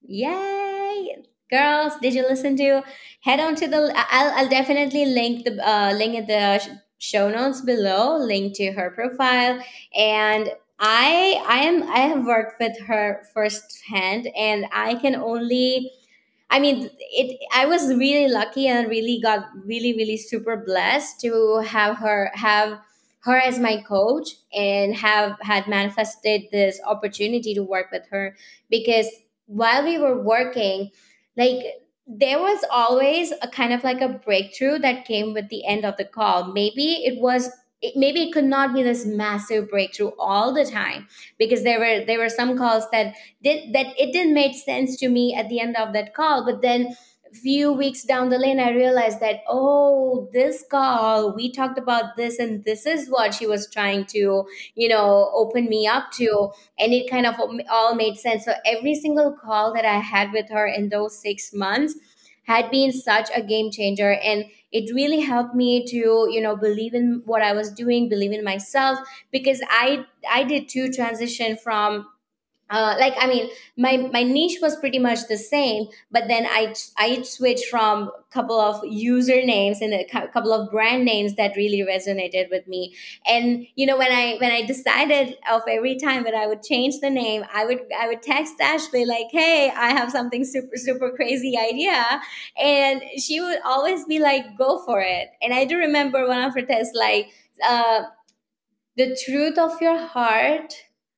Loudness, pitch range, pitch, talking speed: -21 LUFS, 215-265 Hz, 240 Hz, 180 wpm